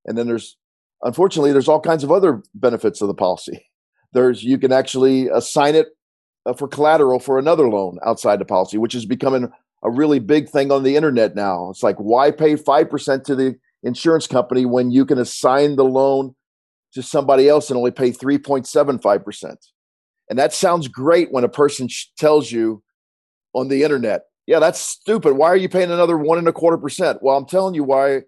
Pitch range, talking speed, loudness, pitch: 125-150 Hz, 190 wpm, -17 LUFS, 135 Hz